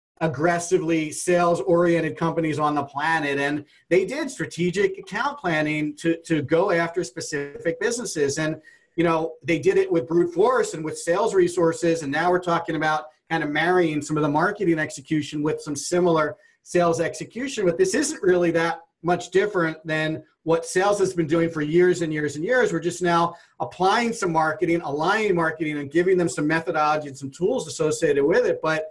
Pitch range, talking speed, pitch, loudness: 155-180 Hz, 185 wpm, 165 Hz, -23 LUFS